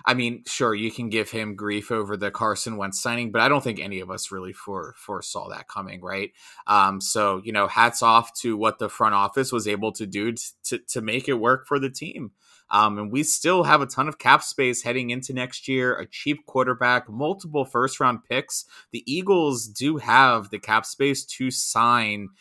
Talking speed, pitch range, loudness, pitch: 215 wpm, 105-130 Hz, -23 LUFS, 120 Hz